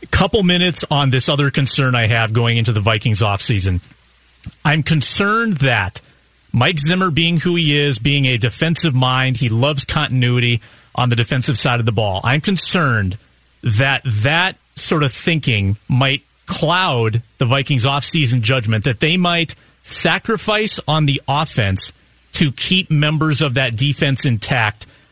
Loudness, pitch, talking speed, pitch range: -16 LUFS, 135 Hz, 155 wpm, 115-155 Hz